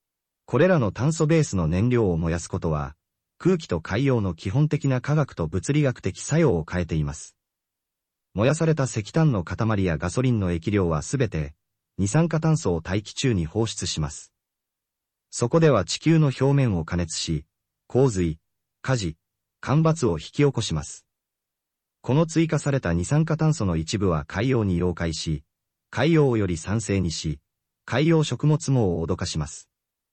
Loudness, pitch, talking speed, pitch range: -24 LUFS, 105 Hz, 300 characters per minute, 85-140 Hz